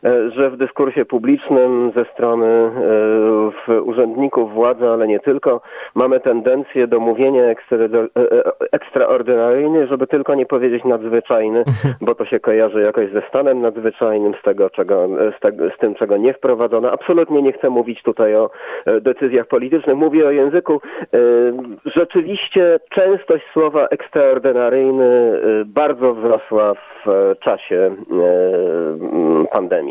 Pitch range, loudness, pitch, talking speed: 120-195 Hz, -15 LUFS, 135 Hz, 140 wpm